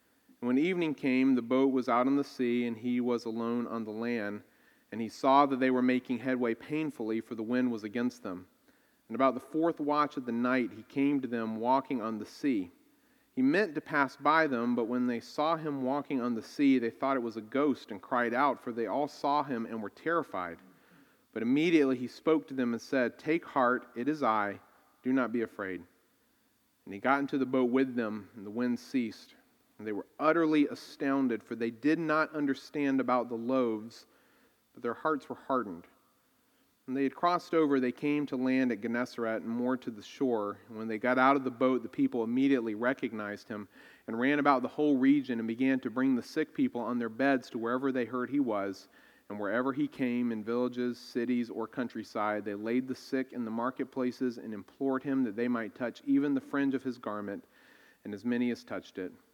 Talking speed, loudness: 215 wpm, -31 LUFS